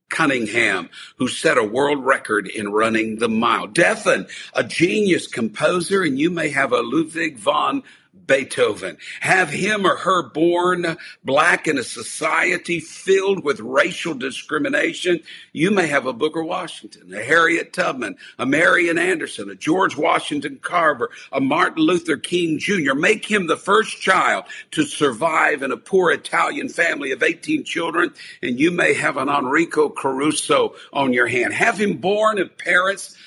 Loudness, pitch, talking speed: -19 LUFS, 215 Hz, 155 wpm